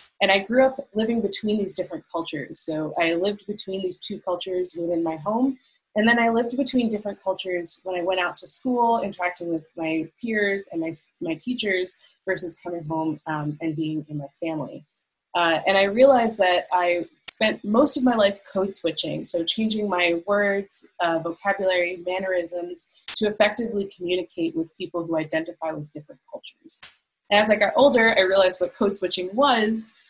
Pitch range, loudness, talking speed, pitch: 170-210 Hz, -23 LUFS, 180 wpm, 185 Hz